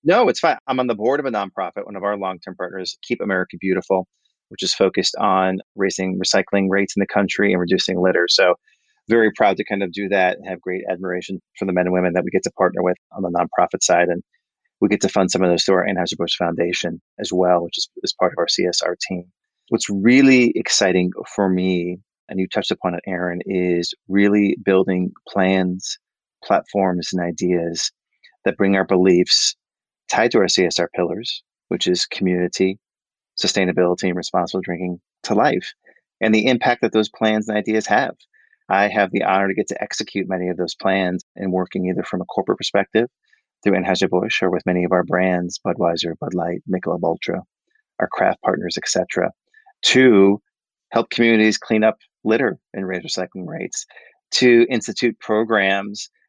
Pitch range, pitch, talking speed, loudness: 90-105 Hz, 95 Hz, 190 wpm, -19 LUFS